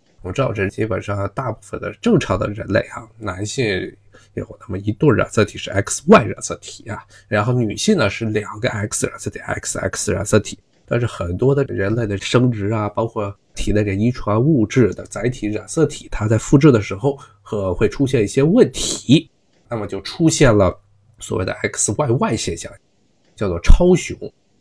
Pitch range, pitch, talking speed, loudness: 105-125 Hz, 110 Hz, 265 characters per minute, -18 LUFS